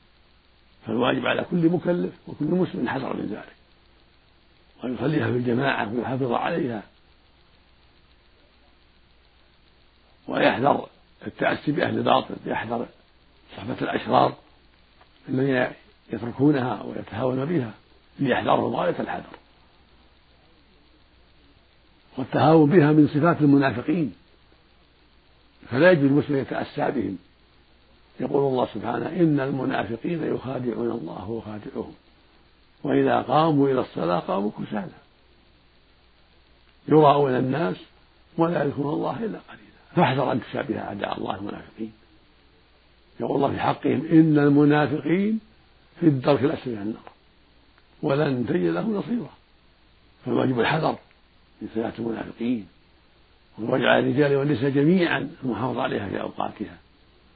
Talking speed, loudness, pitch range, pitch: 100 wpm, -23 LUFS, 100-150 Hz, 130 Hz